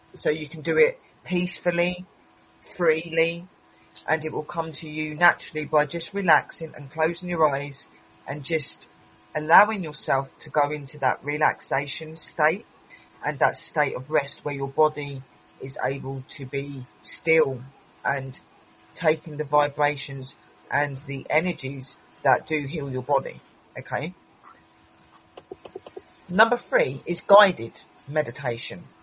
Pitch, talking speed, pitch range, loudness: 150 Hz, 130 wpm, 135-160 Hz, -25 LUFS